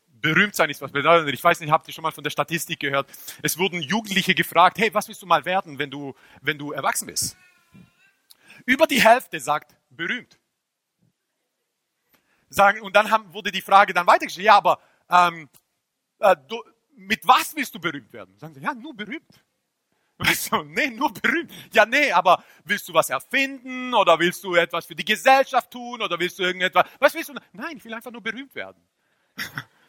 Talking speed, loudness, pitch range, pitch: 190 wpm, -21 LUFS, 165-240 Hz, 195 Hz